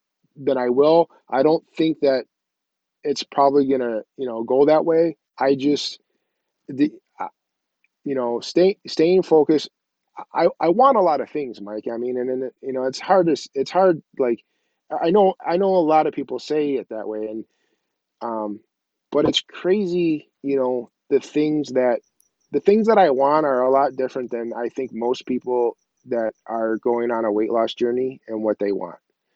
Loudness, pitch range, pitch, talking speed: -21 LUFS, 120-160 Hz, 135 Hz, 190 wpm